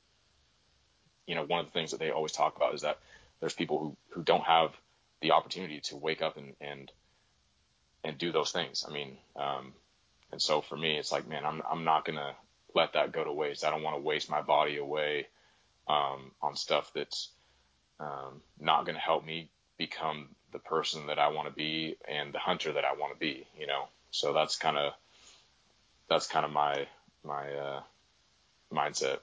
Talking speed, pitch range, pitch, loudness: 200 wpm, 65-75 Hz, 70 Hz, -33 LUFS